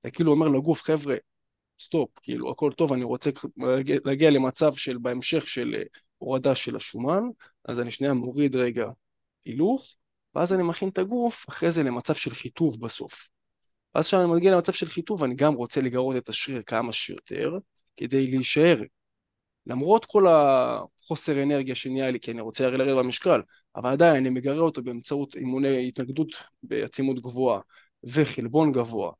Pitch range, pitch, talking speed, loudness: 125-160 Hz, 135 Hz, 155 wpm, -25 LUFS